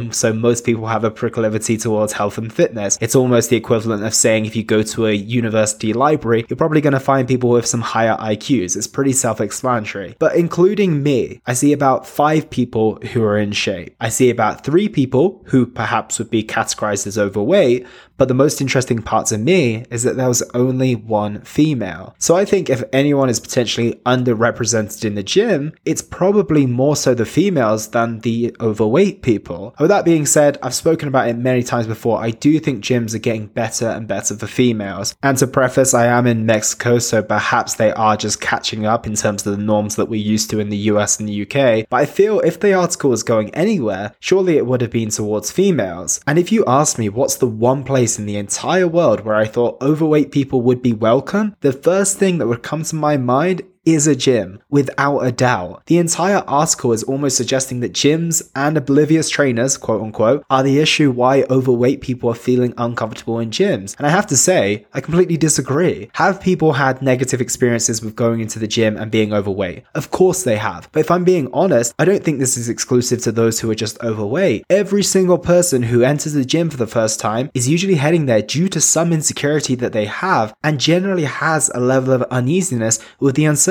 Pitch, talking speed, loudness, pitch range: 125 Hz, 215 wpm, -16 LUFS, 110-150 Hz